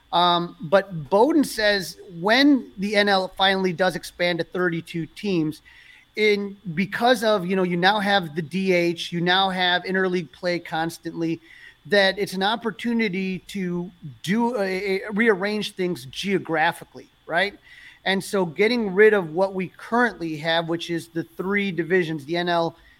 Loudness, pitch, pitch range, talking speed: -22 LUFS, 185 Hz, 170-205 Hz, 150 wpm